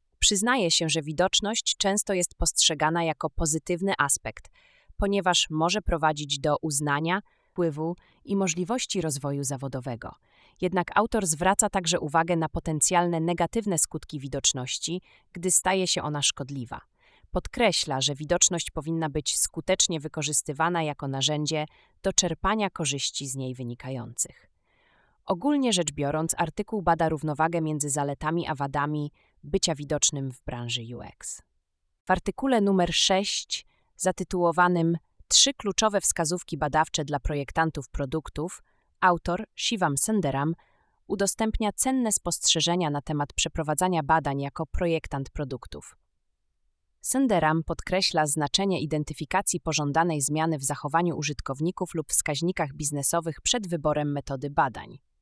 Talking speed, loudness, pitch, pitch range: 115 wpm, -26 LUFS, 160 Hz, 145-180 Hz